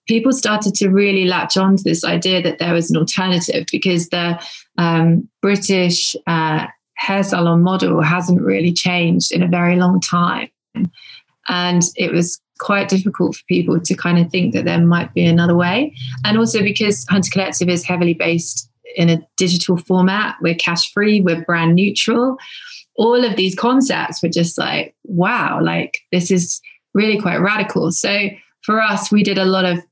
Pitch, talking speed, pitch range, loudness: 180 Hz, 170 wpm, 170-200 Hz, -16 LUFS